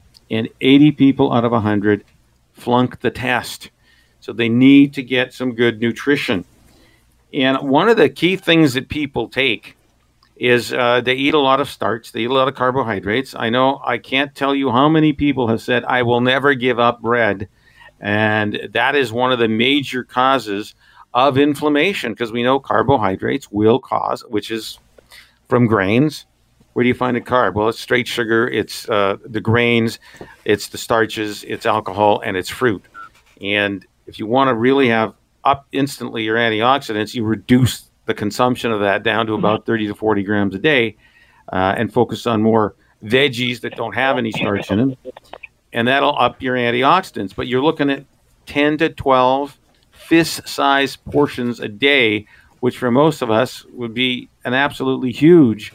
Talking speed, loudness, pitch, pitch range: 180 wpm, -17 LUFS, 120 Hz, 110-135 Hz